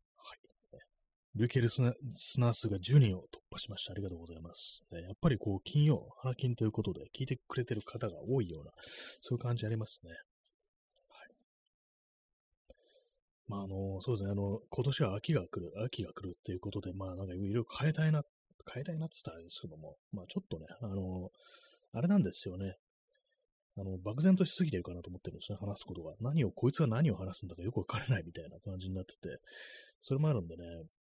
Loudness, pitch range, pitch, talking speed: -36 LUFS, 95-130 Hz, 110 Hz, 400 characters per minute